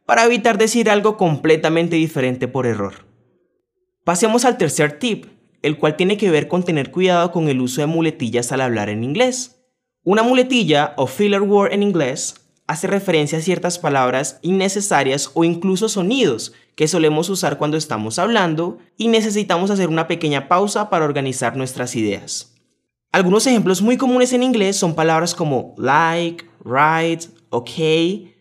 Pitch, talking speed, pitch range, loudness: 170 Hz, 155 wpm, 150-205 Hz, -17 LUFS